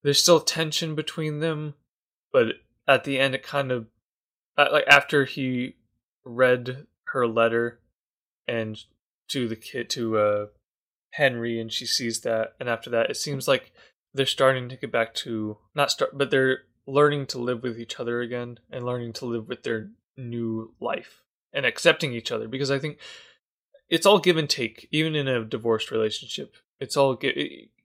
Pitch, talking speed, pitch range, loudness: 125 Hz, 175 wpm, 115-140 Hz, -24 LUFS